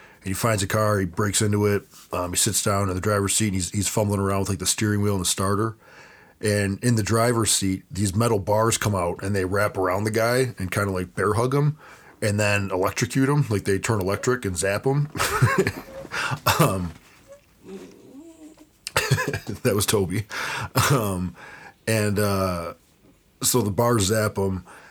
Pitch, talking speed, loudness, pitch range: 105 Hz, 180 wpm, -23 LUFS, 95-115 Hz